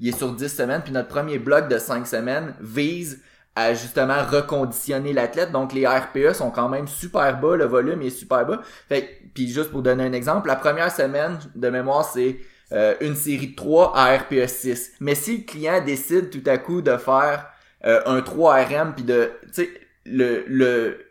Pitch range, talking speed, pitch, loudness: 130-150 Hz, 195 wpm, 140 Hz, -21 LUFS